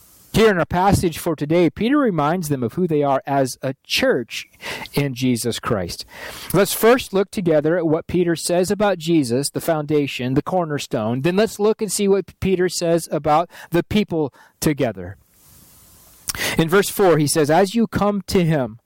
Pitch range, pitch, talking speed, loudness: 145-190 Hz, 165 Hz, 175 wpm, -19 LUFS